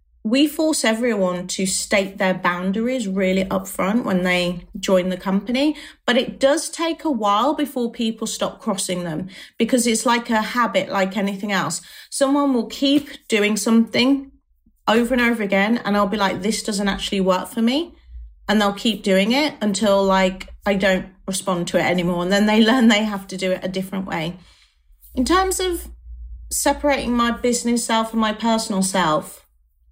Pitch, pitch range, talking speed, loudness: 210 Hz, 190-240 Hz, 175 wpm, -20 LUFS